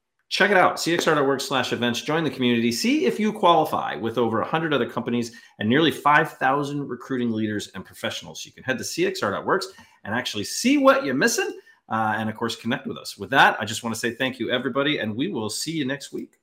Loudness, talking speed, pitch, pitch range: -23 LUFS, 220 wpm, 125 Hz, 115-160 Hz